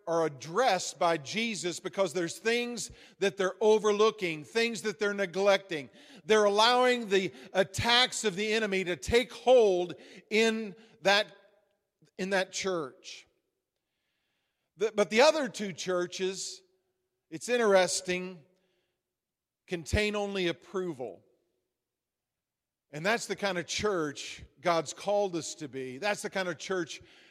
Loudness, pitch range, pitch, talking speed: -29 LUFS, 180-215 Hz, 195 Hz, 120 wpm